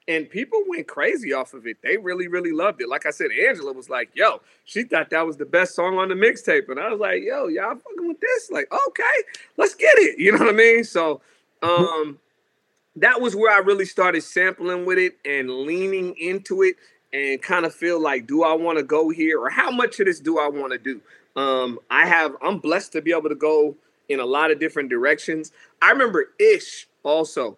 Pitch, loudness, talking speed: 180 Hz, -20 LUFS, 225 wpm